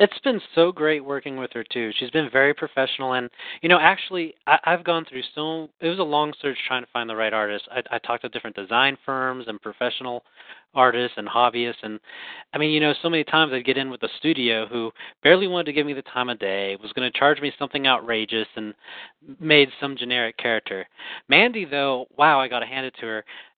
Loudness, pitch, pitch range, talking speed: -22 LUFS, 130 Hz, 120-150 Hz, 225 wpm